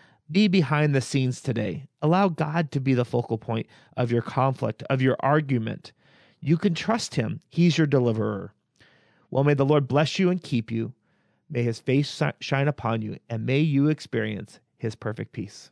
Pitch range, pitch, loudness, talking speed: 120-155 Hz, 135 Hz, -25 LUFS, 180 wpm